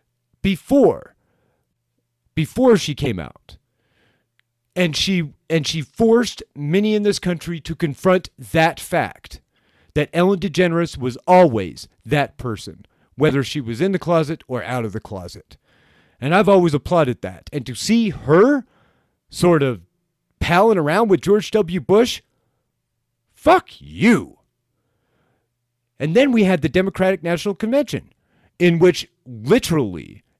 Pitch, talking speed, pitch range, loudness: 160 Hz, 130 wpm, 125-185 Hz, -18 LUFS